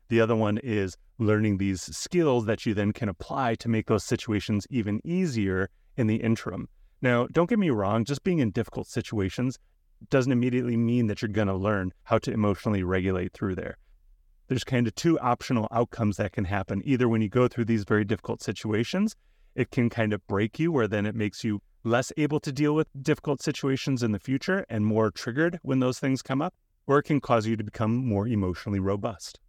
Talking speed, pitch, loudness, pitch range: 210 wpm, 115 Hz, -27 LUFS, 105-130 Hz